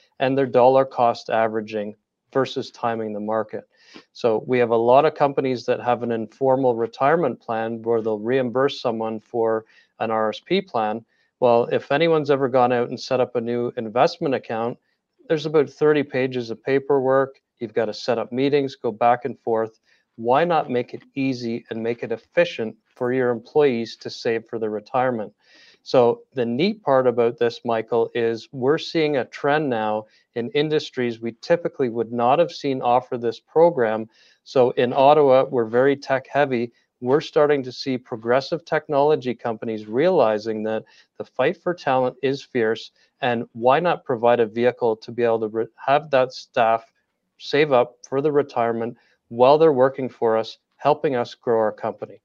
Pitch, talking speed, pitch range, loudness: 120 Hz, 175 wpm, 115-135 Hz, -21 LUFS